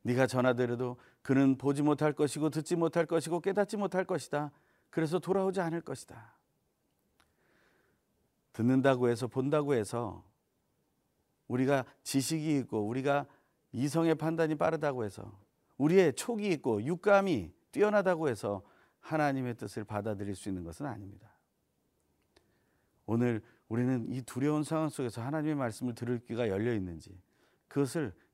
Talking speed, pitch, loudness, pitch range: 310 characters per minute, 135 Hz, -32 LUFS, 120-160 Hz